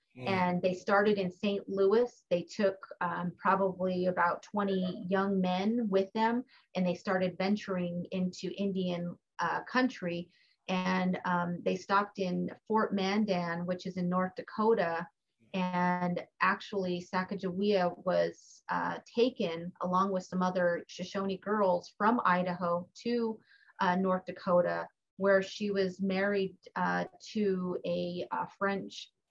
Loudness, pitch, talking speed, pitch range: -32 LUFS, 185 Hz, 130 wpm, 180-200 Hz